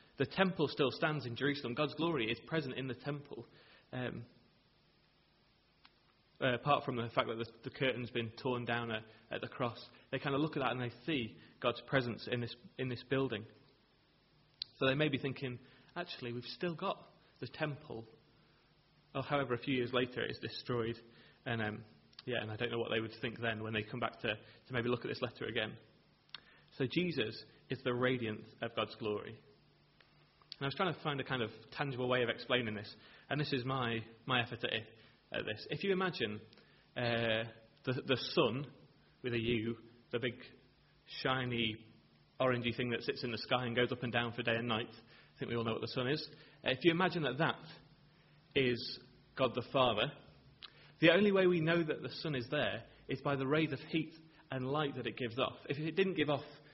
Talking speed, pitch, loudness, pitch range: 205 wpm, 125 Hz, -37 LUFS, 115-145 Hz